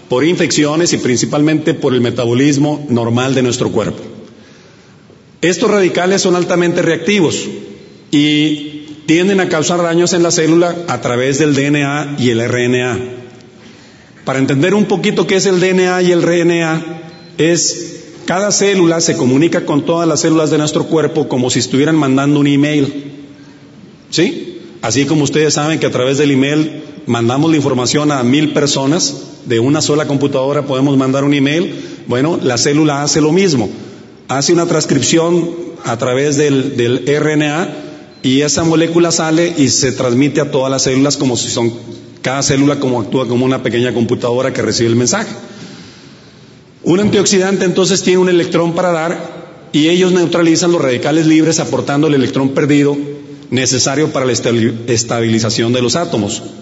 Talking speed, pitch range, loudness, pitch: 160 wpm, 130-165 Hz, -13 LUFS, 150 Hz